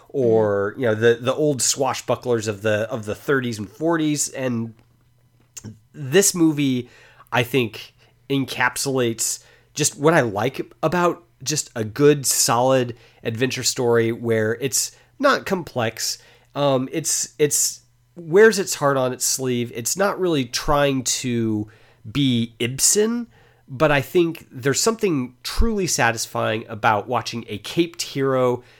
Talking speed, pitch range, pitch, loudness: 130 wpm, 115-145 Hz, 125 Hz, -21 LUFS